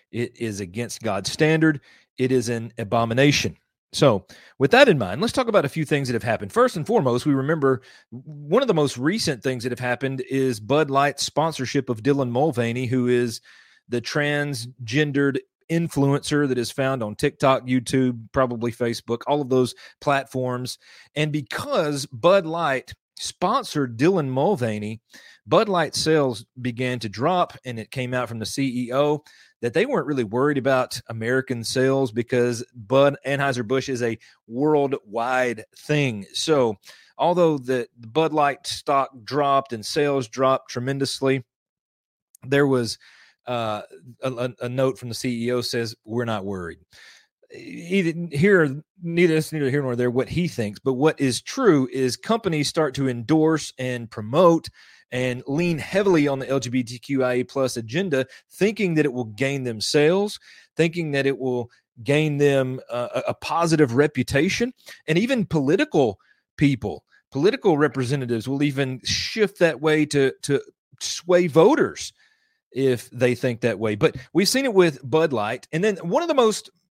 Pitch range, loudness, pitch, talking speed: 125-155 Hz, -22 LUFS, 135 Hz, 155 wpm